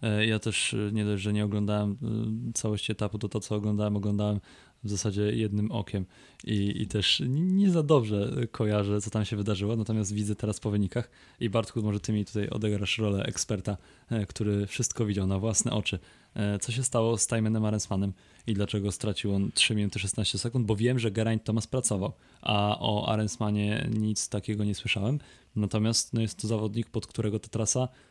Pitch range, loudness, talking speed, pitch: 105-115 Hz, -29 LUFS, 180 wpm, 105 Hz